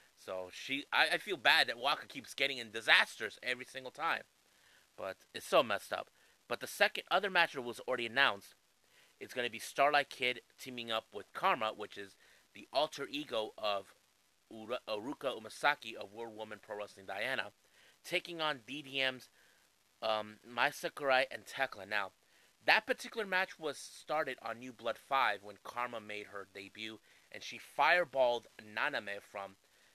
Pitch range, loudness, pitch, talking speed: 105-140 Hz, -35 LUFS, 120 Hz, 160 wpm